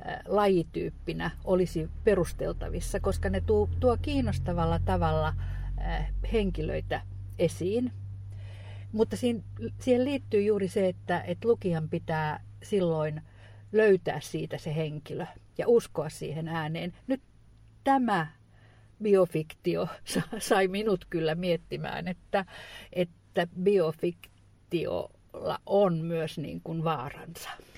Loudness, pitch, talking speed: -30 LUFS, 160 Hz, 95 wpm